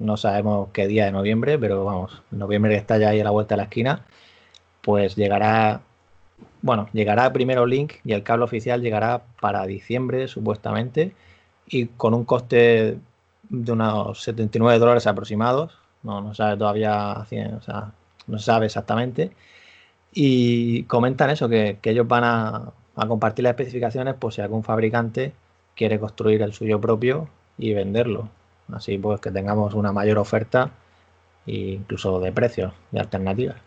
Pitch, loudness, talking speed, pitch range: 110 Hz, -22 LUFS, 155 wpm, 105-120 Hz